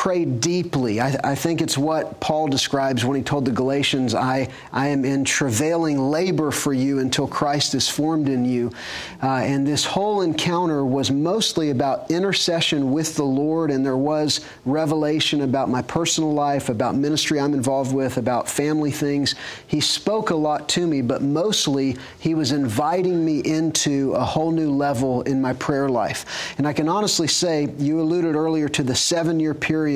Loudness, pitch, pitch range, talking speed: -21 LUFS, 145 Hz, 135-160 Hz, 180 wpm